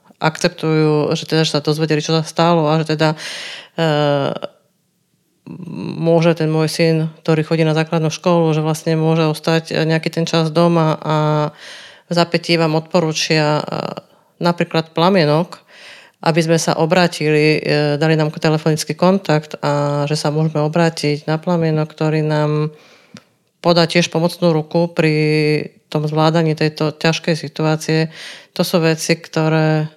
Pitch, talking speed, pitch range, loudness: 160 Hz, 140 wpm, 155-170 Hz, -16 LUFS